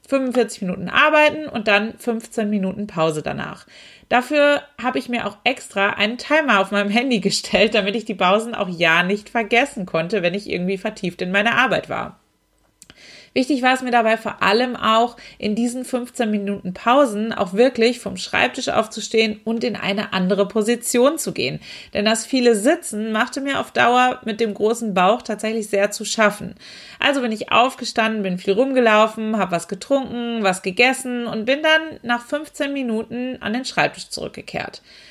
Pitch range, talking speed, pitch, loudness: 205-245 Hz, 175 wpm, 225 Hz, -19 LUFS